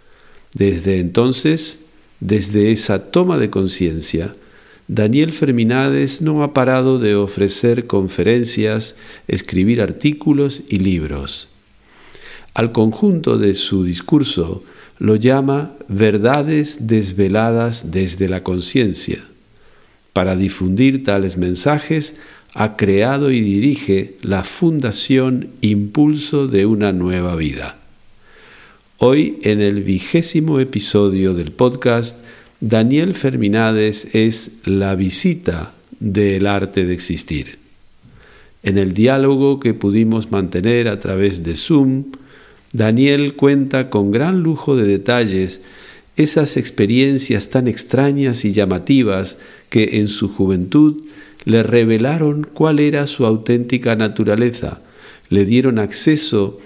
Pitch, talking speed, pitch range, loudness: 110 Hz, 105 wpm, 100-135 Hz, -16 LUFS